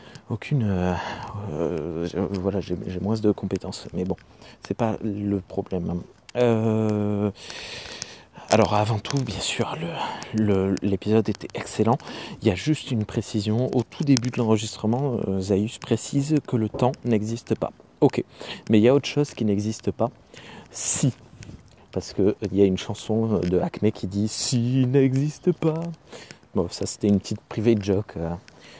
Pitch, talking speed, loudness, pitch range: 110 Hz, 160 wpm, -25 LUFS, 100-120 Hz